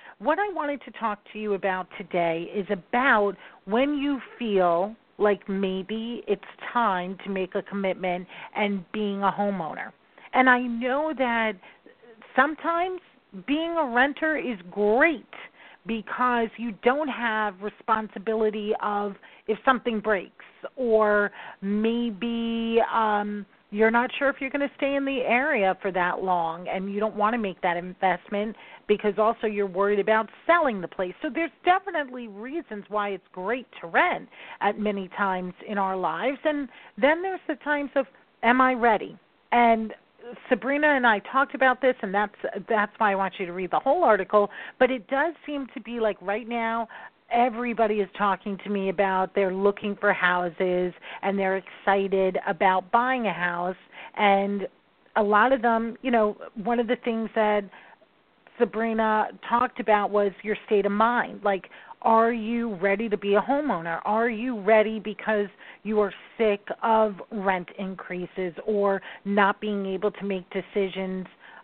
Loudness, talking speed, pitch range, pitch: -25 LUFS, 160 wpm, 200-245 Hz, 215 Hz